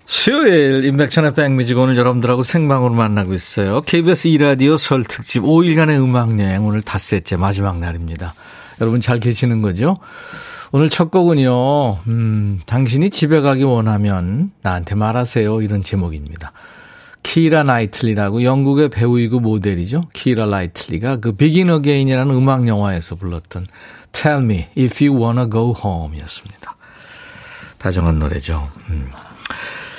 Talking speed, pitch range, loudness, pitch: 350 characters per minute, 100-145 Hz, -15 LUFS, 120 Hz